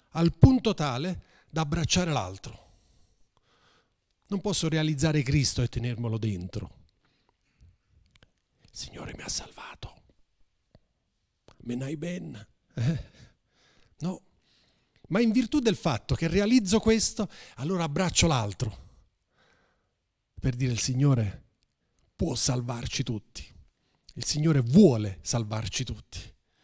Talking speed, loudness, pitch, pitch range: 100 wpm, -27 LUFS, 140 Hz, 120-180 Hz